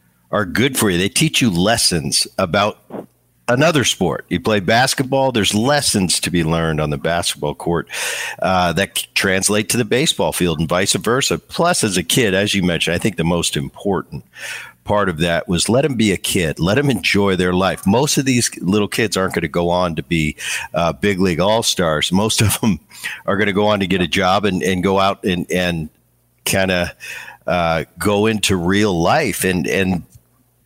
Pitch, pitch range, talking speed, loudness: 95 Hz, 85-105 Hz, 200 wpm, -17 LUFS